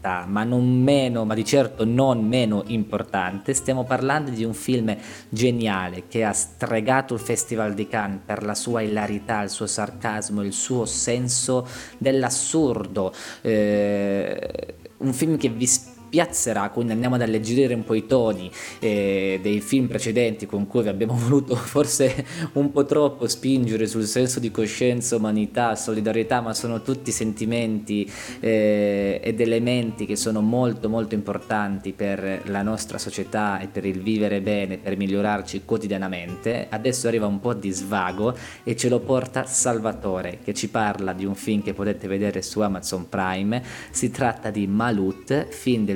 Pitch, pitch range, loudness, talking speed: 110 Hz, 100-125 Hz, -23 LUFS, 155 wpm